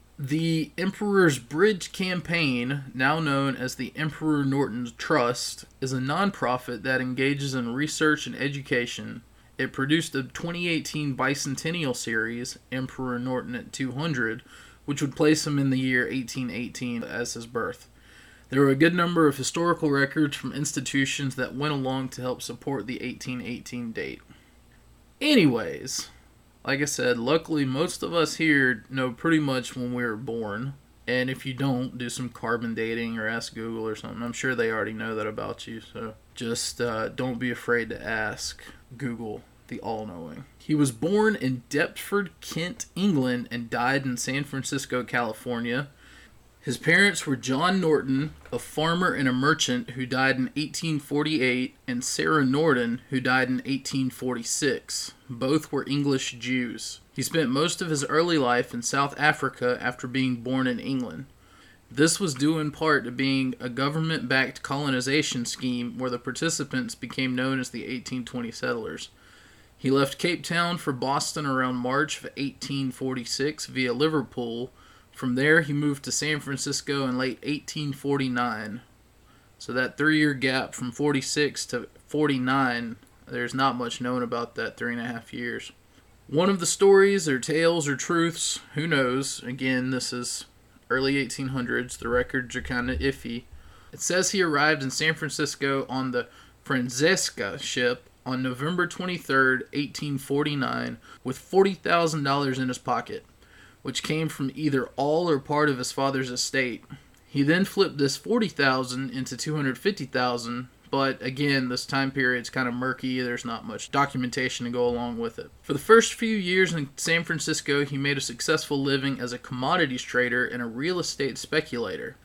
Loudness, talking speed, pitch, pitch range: -26 LUFS, 160 wpm, 135 Hz, 125-150 Hz